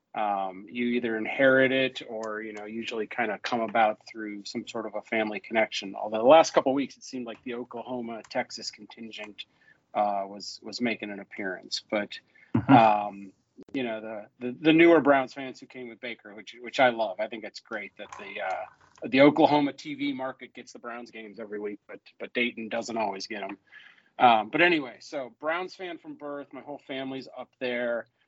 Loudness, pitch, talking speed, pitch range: -27 LUFS, 120 Hz, 200 wpm, 110-130 Hz